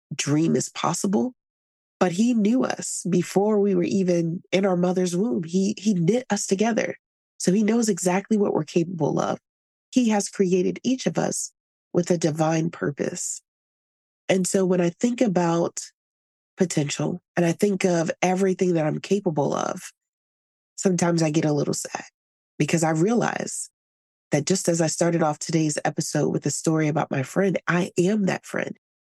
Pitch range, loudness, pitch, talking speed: 160-195 Hz, -23 LUFS, 180 Hz, 165 wpm